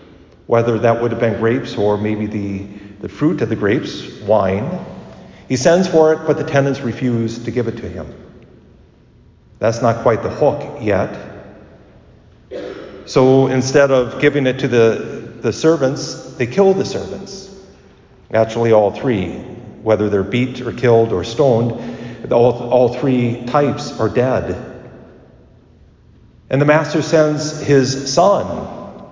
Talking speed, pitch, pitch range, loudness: 140 wpm, 125 Hz, 110-145 Hz, -16 LUFS